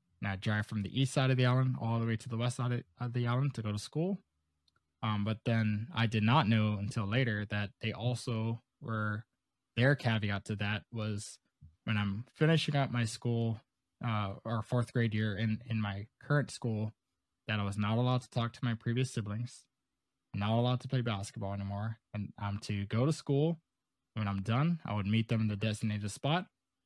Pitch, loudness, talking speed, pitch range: 115 Hz, -34 LUFS, 210 wpm, 105-125 Hz